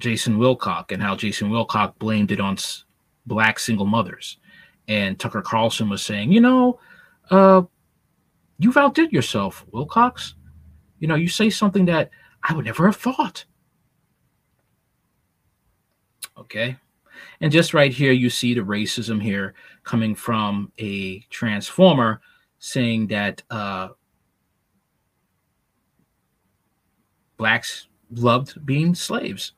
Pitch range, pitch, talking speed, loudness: 105-170 Hz, 120 Hz, 115 wpm, -20 LUFS